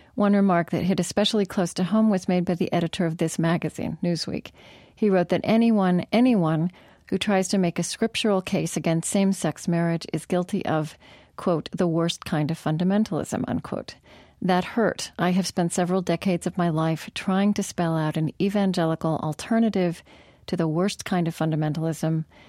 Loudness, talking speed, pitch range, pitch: -24 LUFS, 175 wpm, 165-195 Hz, 180 Hz